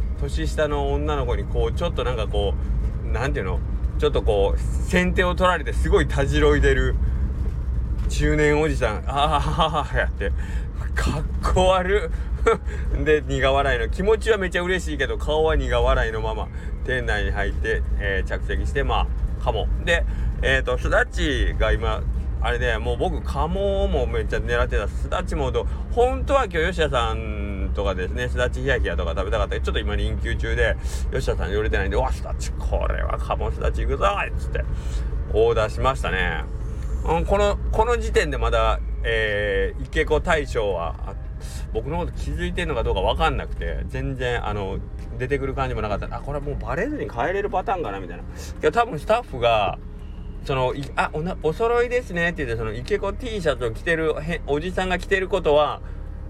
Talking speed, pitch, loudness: 365 characters per minute, 95 Hz, -23 LUFS